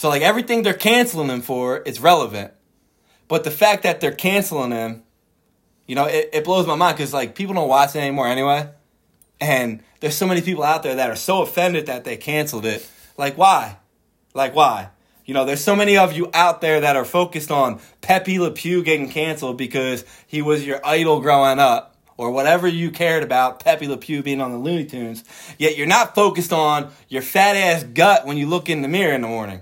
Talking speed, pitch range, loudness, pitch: 210 wpm, 135-175 Hz, -18 LUFS, 150 Hz